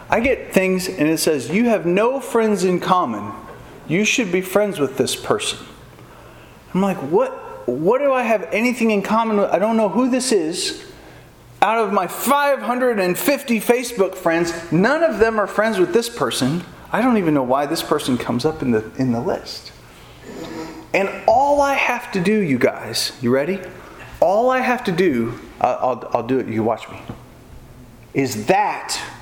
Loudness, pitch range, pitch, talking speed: -19 LUFS, 155-245 Hz, 200 Hz, 180 wpm